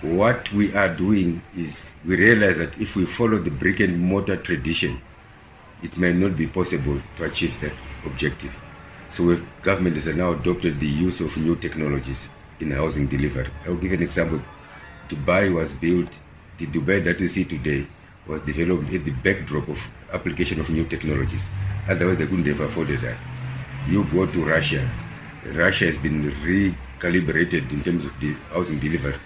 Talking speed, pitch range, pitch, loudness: 170 wpm, 75-95 Hz, 85 Hz, -23 LUFS